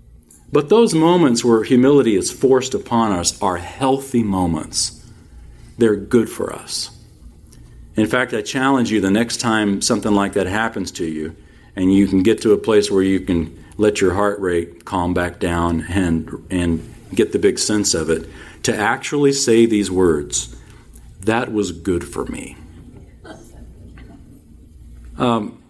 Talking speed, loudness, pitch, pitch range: 155 wpm, -18 LUFS, 100 Hz, 85-115 Hz